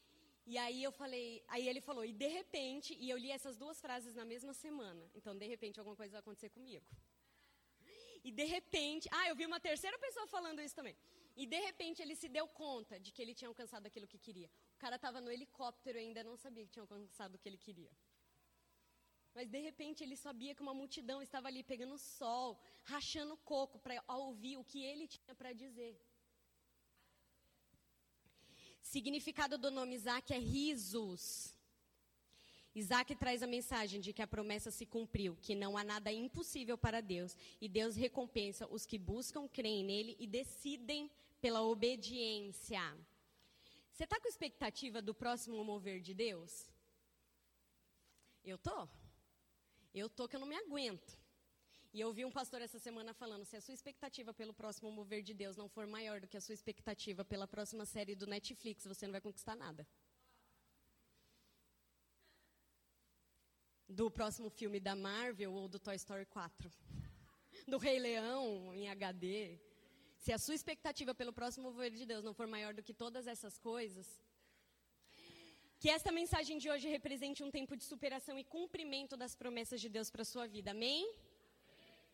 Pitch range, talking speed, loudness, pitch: 210-275 Hz, 170 wpm, -45 LUFS, 235 Hz